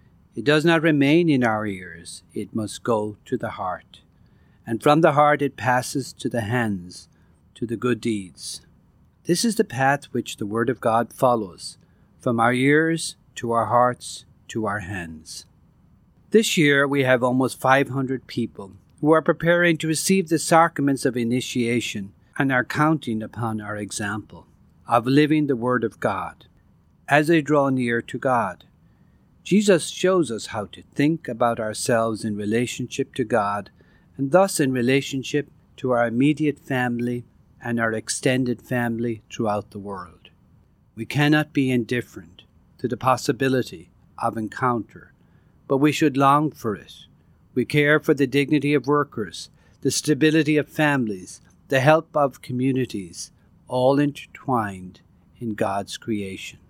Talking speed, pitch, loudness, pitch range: 150 wpm, 125 Hz, -22 LUFS, 110-145 Hz